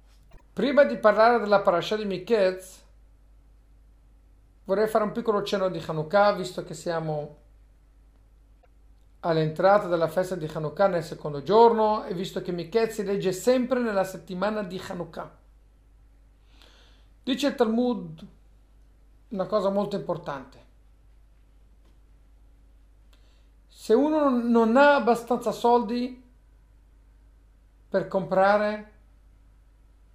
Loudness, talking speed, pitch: -24 LUFS, 100 wpm, 185 Hz